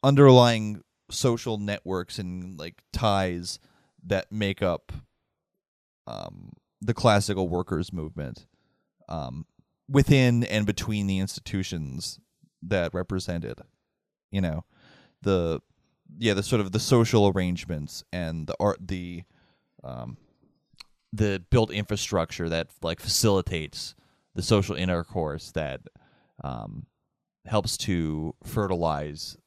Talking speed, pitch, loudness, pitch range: 105 wpm, 95 Hz, -26 LUFS, 85-105 Hz